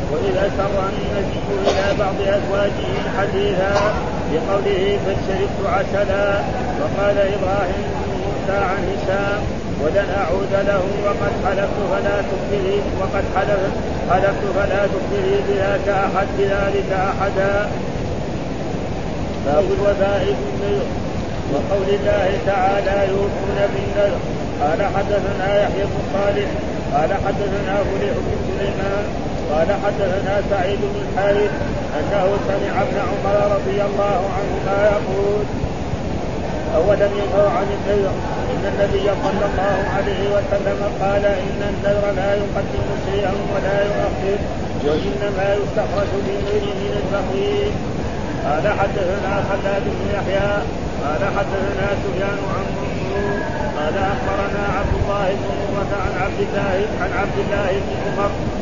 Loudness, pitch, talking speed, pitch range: -20 LUFS, 195 Hz, 110 wpm, 190-200 Hz